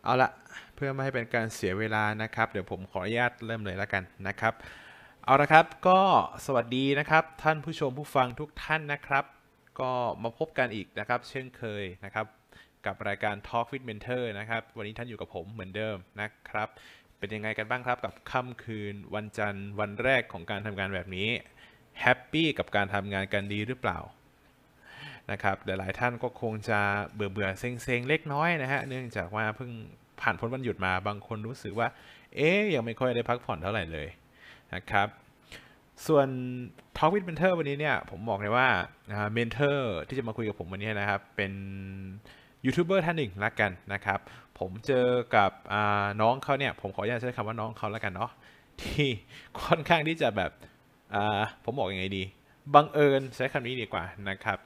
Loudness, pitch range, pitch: -30 LUFS, 100-135 Hz, 115 Hz